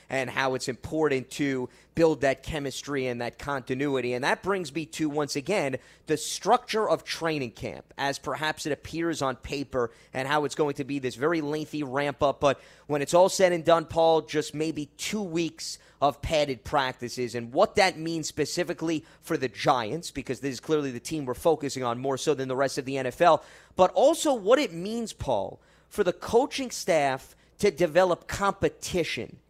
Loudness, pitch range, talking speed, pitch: -27 LUFS, 135-170 Hz, 190 wpm, 150 Hz